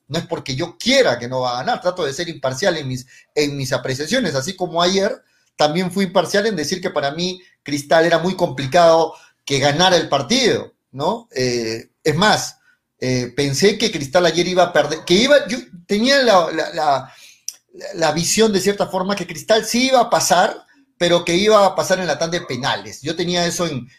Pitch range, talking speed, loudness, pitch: 145-190 Hz, 205 wpm, -18 LUFS, 175 Hz